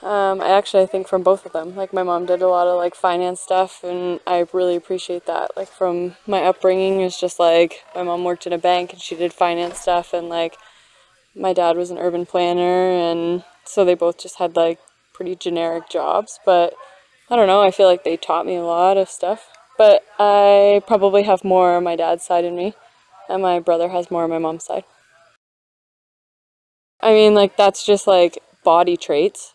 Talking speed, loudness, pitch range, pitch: 205 wpm, -18 LUFS, 175-190 Hz, 180 Hz